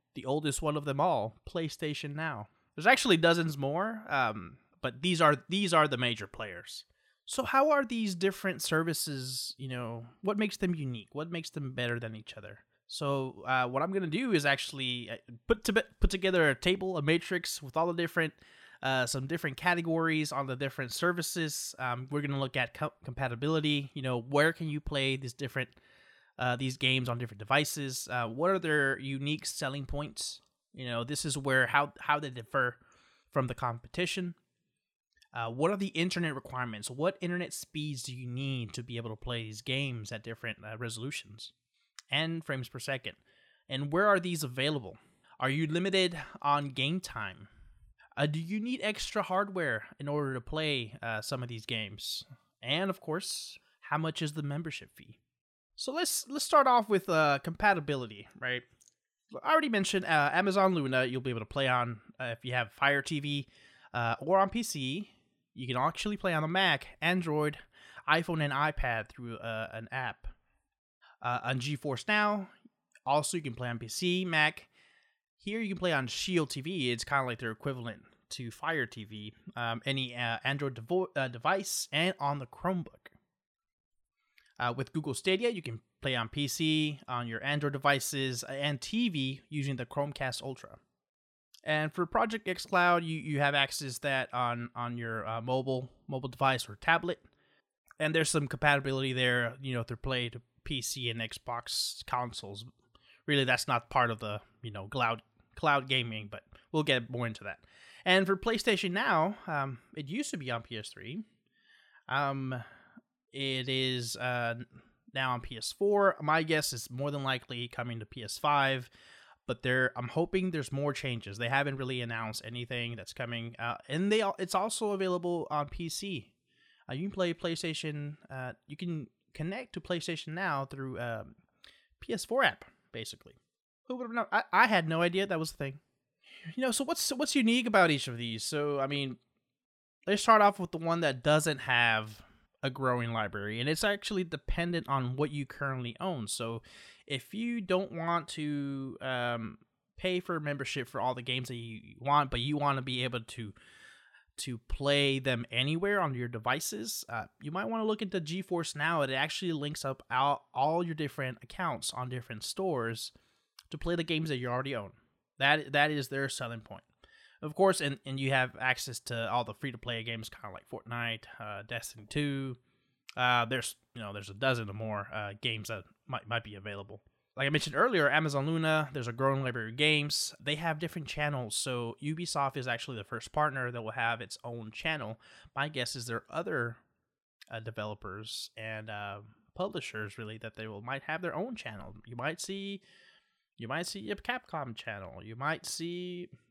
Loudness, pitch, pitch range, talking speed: -32 LUFS, 140 Hz, 120-165 Hz, 185 wpm